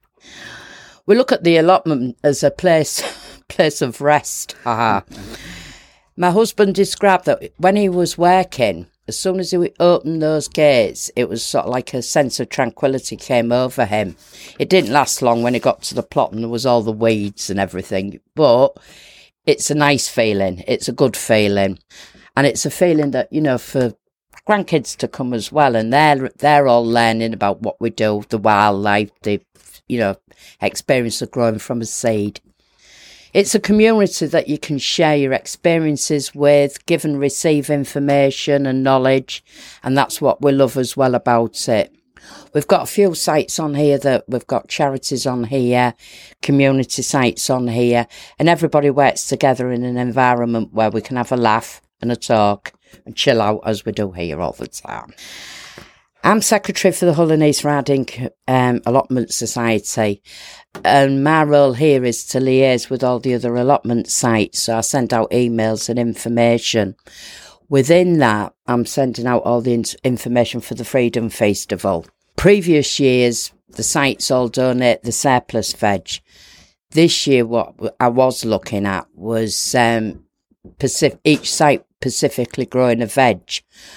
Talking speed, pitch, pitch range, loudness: 170 wpm, 125 Hz, 115-145 Hz, -17 LUFS